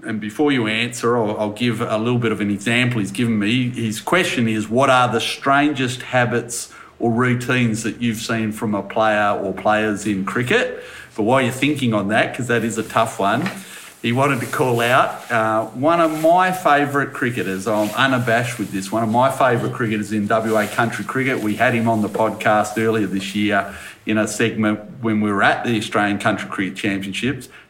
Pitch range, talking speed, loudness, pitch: 105-125 Hz, 200 wpm, -19 LUFS, 115 Hz